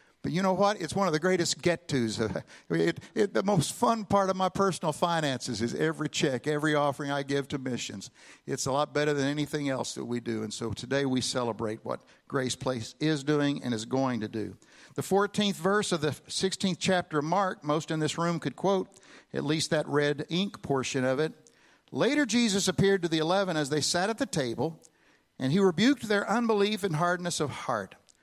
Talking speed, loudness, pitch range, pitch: 205 wpm, -29 LUFS, 135-185 Hz, 155 Hz